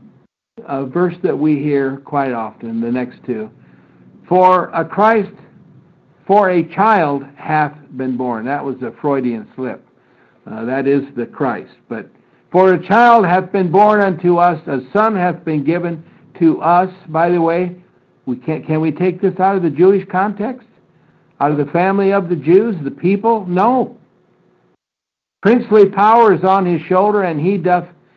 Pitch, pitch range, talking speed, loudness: 175 Hz, 150-195 Hz, 165 wpm, -15 LUFS